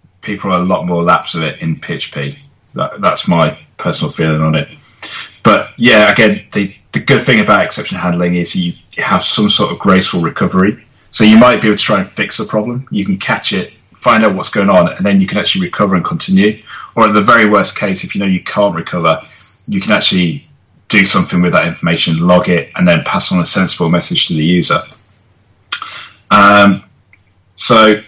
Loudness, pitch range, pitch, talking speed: -11 LUFS, 90-110 Hz, 95 Hz, 205 wpm